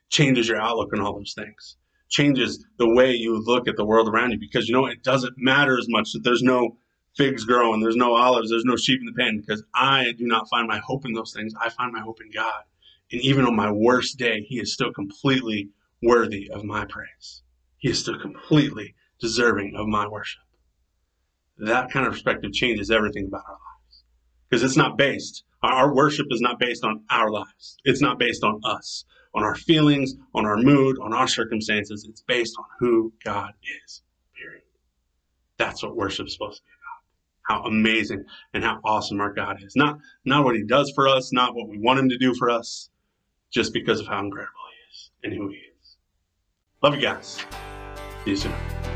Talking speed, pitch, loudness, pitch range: 205 wpm, 115 Hz, -22 LUFS, 105-125 Hz